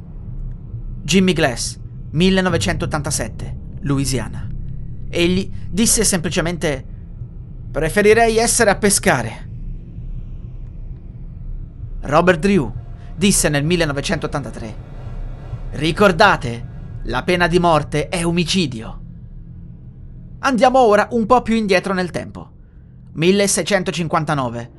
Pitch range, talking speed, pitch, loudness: 120-185 Hz, 75 wpm, 155 Hz, -17 LUFS